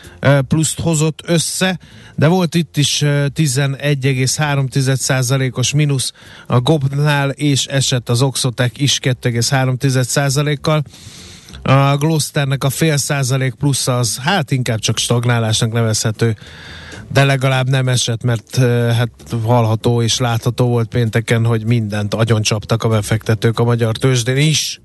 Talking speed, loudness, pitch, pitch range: 120 wpm, -15 LUFS, 130 Hz, 120-140 Hz